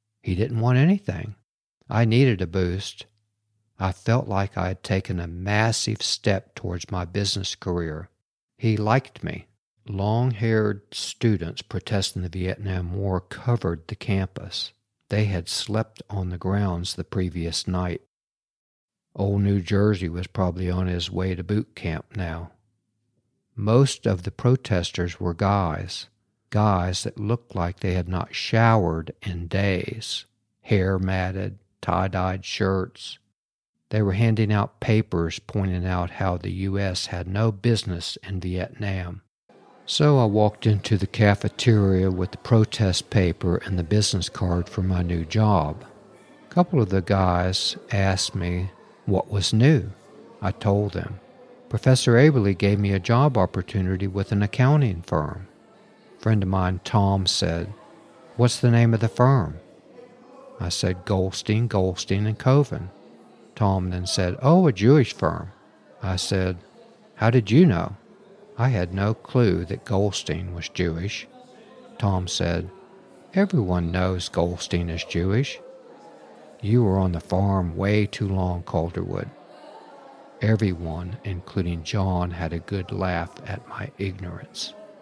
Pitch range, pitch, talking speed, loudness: 90-110 Hz, 100 Hz, 140 wpm, -24 LUFS